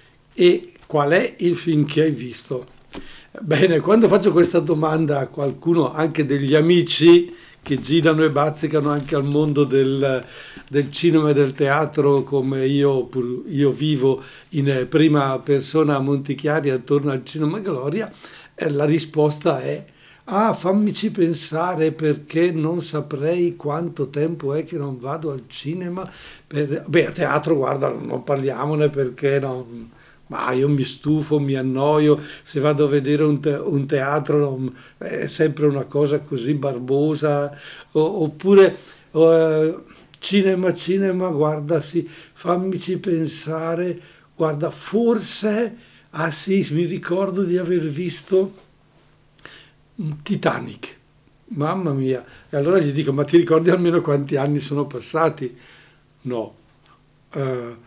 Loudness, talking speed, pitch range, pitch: -20 LUFS, 125 wpm, 140-170 Hz, 150 Hz